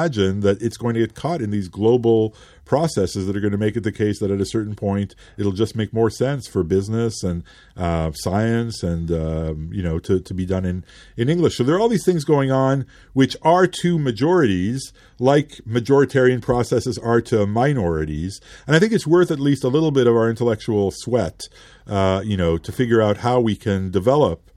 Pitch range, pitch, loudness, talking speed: 95-130 Hz, 110 Hz, -20 LUFS, 210 wpm